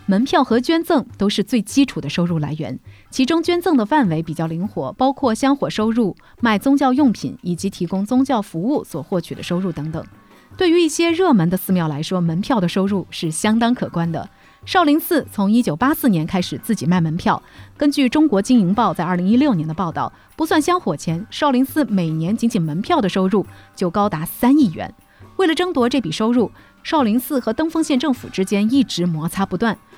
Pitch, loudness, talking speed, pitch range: 215 Hz, -18 LUFS, 310 characters per minute, 180-275 Hz